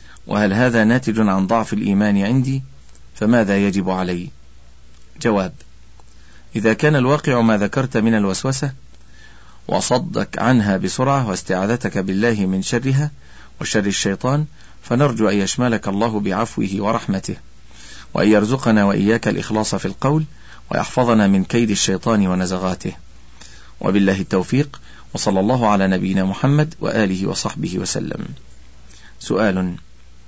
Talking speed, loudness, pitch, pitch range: 110 wpm, -18 LUFS, 100 Hz, 90-120 Hz